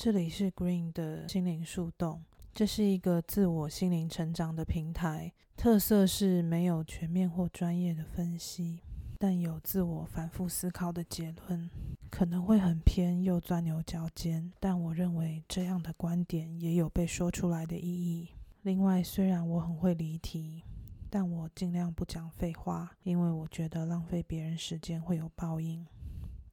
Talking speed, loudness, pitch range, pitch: 250 characters per minute, -33 LUFS, 165-180 Hz, 170 Hz